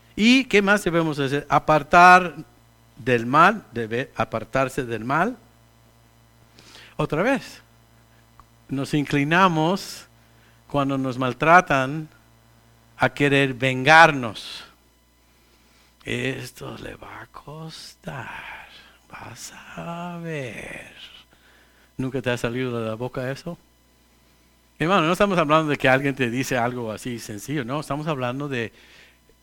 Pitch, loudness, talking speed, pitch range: 130 Hz, -21 LUFS, 110 wpm, 115-155 Hz